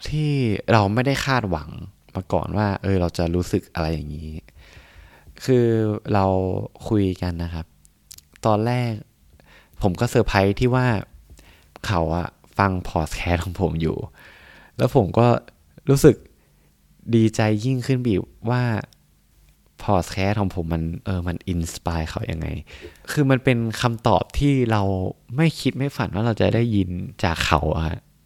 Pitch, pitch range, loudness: 95 Hz, 80-115 Hz, -22 LUFS